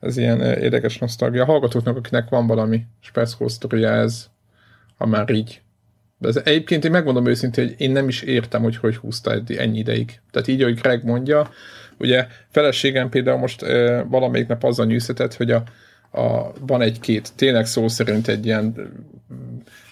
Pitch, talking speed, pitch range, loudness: 120 Hz, 160 wpm, 110-125 Hz, -20 LUFS